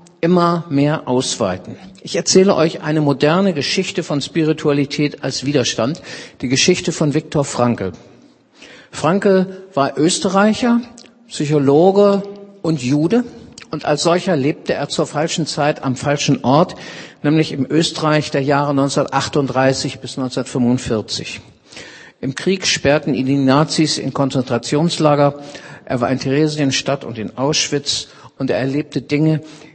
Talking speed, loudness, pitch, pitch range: 125 wpm, -17 LUFS, 150 Hz, 140-170 Hz